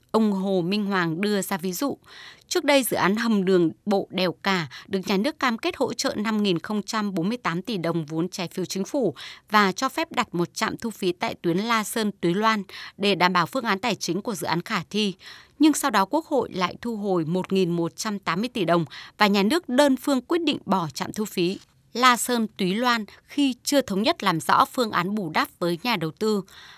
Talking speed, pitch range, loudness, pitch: 220 wpm, 180-240 Hz, -24 LUFS, 200 Hz